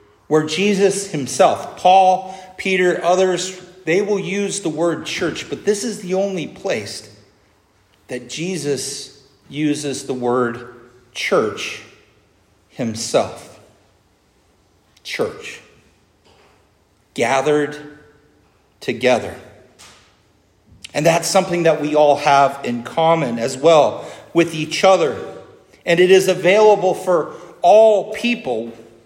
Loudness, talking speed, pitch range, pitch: -17 LUFS, 100 wpm, 115-185 Hz, 150 Hz